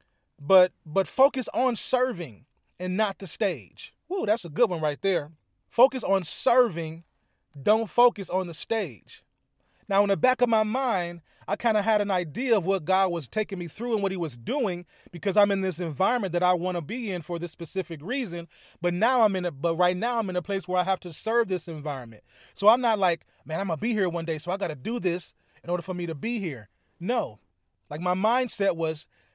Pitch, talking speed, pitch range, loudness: 185 Hz, 225 wpm, 170-220 Hz, -26 LUFS